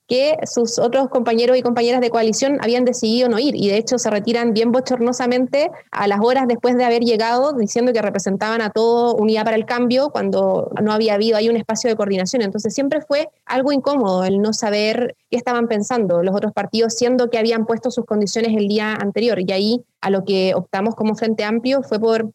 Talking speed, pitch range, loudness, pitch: 210 wpm, 215-245 Hz, -18 LUFS, 230 Hz